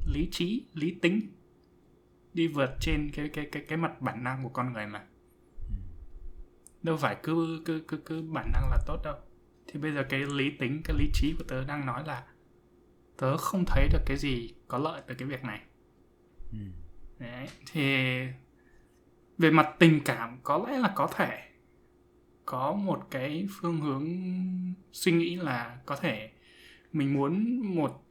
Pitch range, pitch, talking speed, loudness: 115-160 Hz, 140 Hz, 170 wpm, -31 LUFS